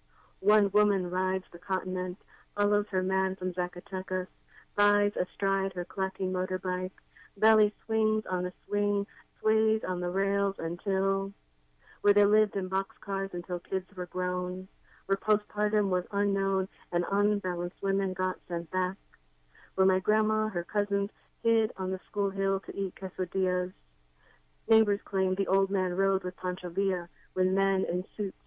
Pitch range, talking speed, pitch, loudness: 185-200 Hz, 150 wpm, 190 Hz, -30 LUFS